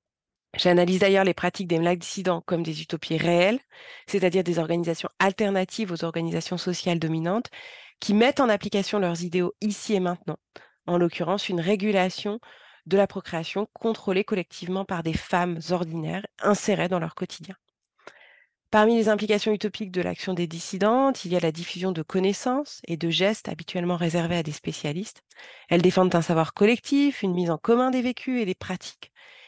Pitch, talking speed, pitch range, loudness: 185 Hz, 165 wpm, 175-210 Hz, -25 LUFS